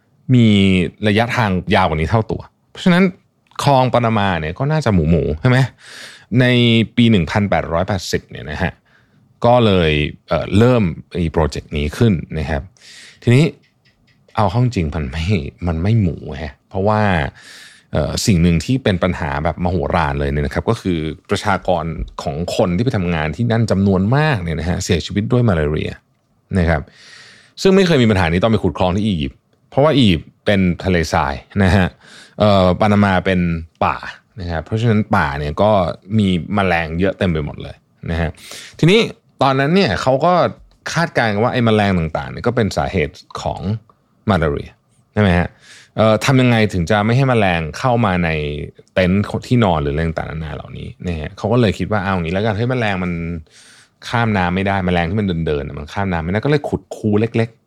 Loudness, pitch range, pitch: -17 LUFS, 85-115 Hz, 95 Hz